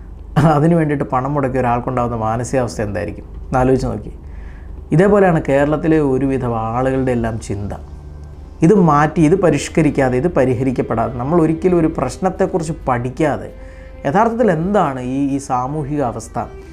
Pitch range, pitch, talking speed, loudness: 110-155 Hz, 130 Hz, 115 wpm, -16 LUFS